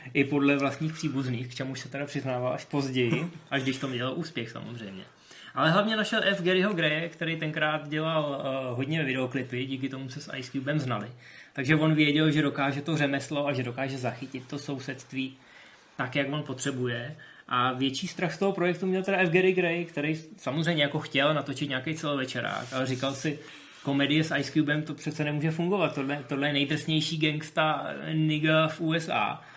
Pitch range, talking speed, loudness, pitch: 135-160 Hz, 185 wpm, -28 LUFS, 145 Hz